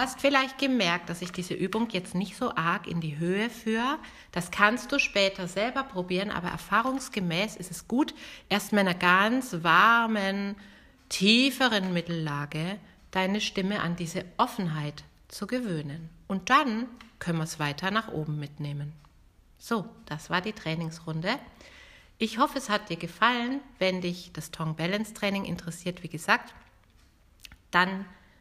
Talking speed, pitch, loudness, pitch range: 145 wpm, 190 Hz, -28 LUFS, 170-225 Hz